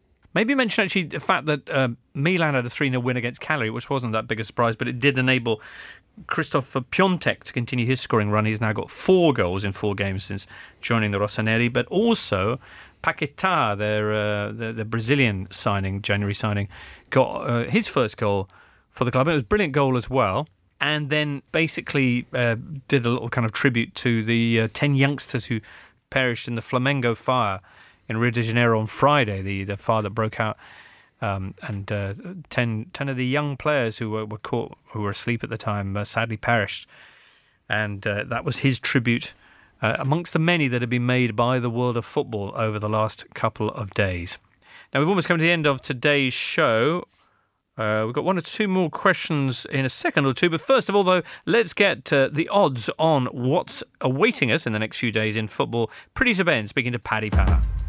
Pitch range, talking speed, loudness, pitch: 110-145 Hz, 205 wpm, -23 LUFS, 120 Hz